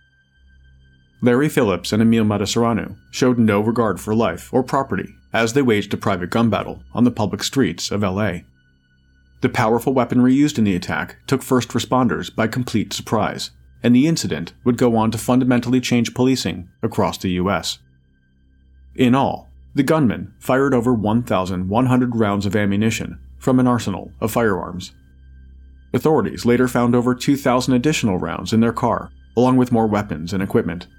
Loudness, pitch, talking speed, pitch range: -19 LUFS, 110 Hz, 160 wpm, 80-125 Hz